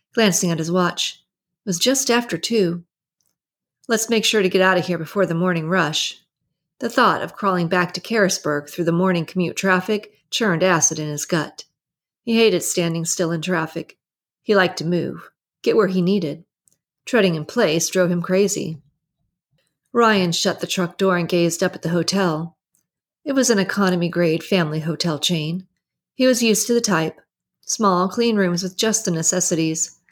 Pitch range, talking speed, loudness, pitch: 165-195 Hz, 180 wpm, -19 LUFS, 180 Hz